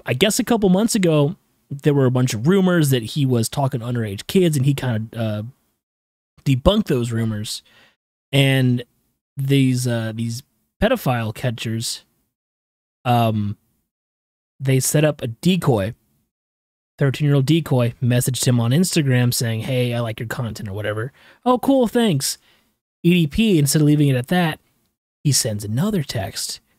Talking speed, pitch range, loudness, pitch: 150 wpm, 115-150 Hz, -19 LUFS, 125 Hz